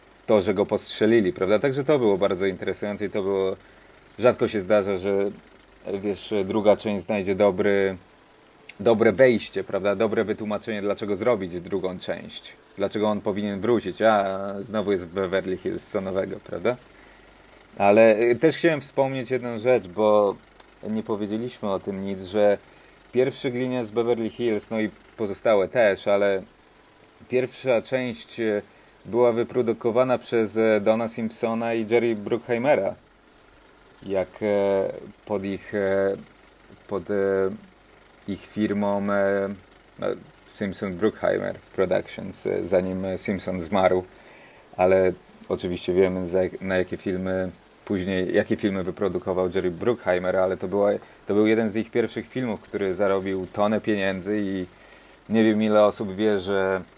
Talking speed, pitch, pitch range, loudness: 130 wpm, 105 Hz, 95-110 Hz, -24 LUFS